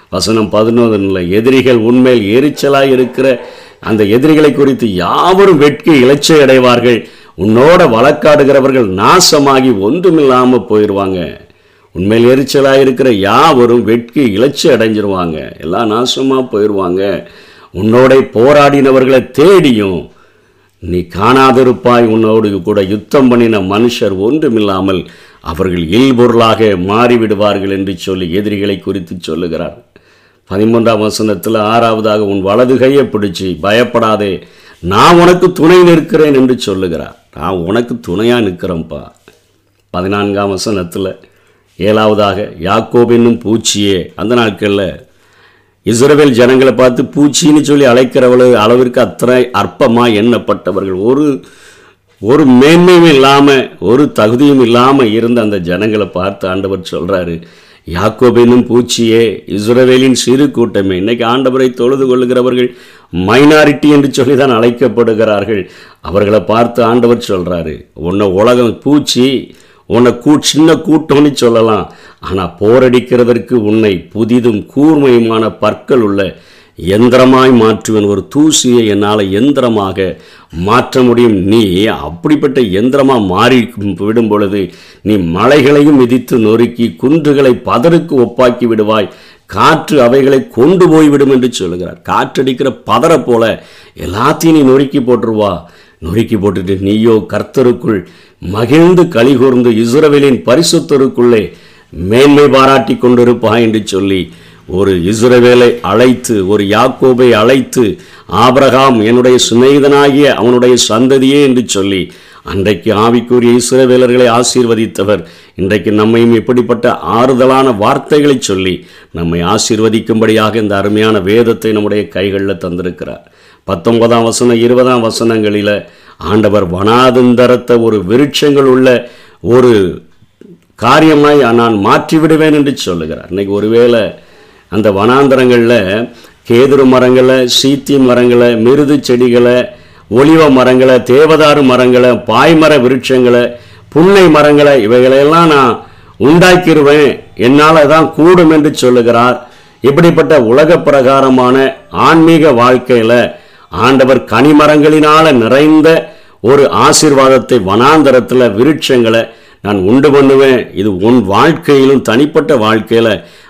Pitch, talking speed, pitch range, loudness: 120 Hz, 95 wpm, 105-135 Hz, -8 LUFS